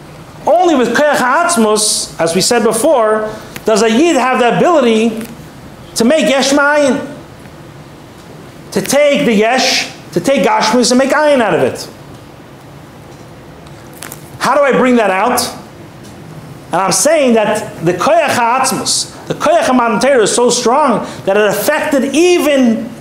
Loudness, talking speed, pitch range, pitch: -11 LUFS, 140 wpm, 220-285 Hz, 245 Hz